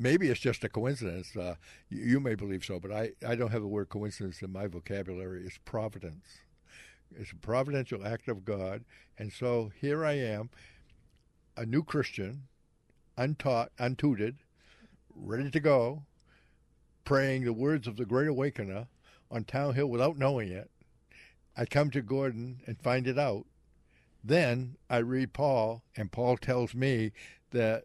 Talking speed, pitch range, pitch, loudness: 155 wpm, 100-135 Hz, 120 Hz, -32 LUFS